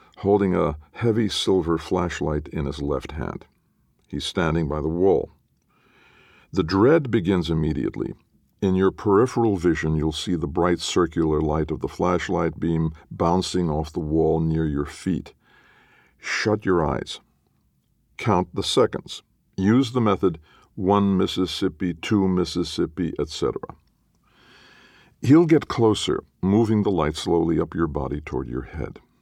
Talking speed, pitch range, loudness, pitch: 135 wpm, 80-100 Hz, -23 LUFS, 85 Hz